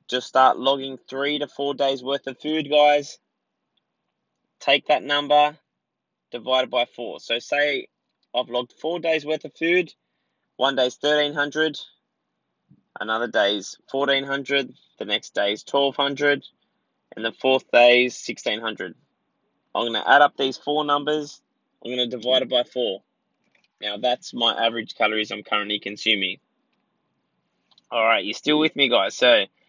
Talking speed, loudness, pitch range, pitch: 150 wpm, -22 LUFS, 125-150 Hz, 140 Hz